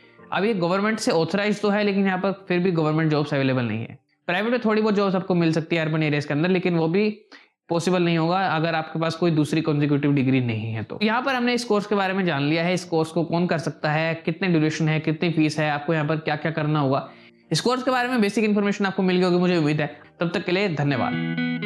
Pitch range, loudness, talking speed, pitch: 155-195 Hz, -22 LUFS, 265 wpm, 165 Hz